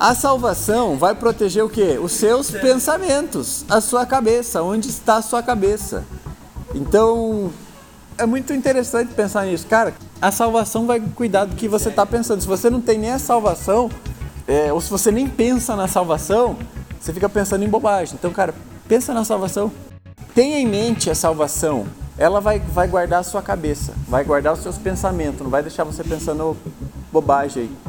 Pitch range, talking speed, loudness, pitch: 170-230 Hz, 175 wpm, -19 LUFS, 205 Hz